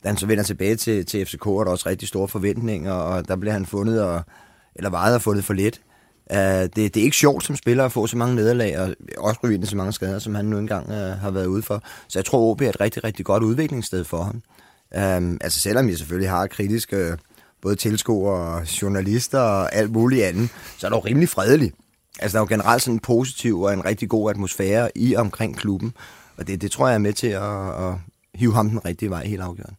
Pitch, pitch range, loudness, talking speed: 105 Hz, 95-115 Hz, -22 LUFS, 245 wpm